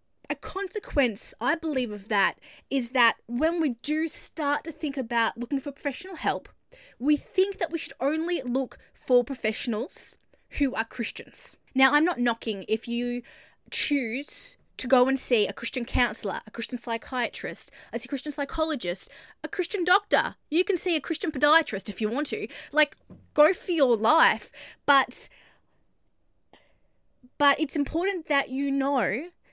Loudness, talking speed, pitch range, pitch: -26 LUFS, 155 wpm, 240-315 Hz, 275 Hz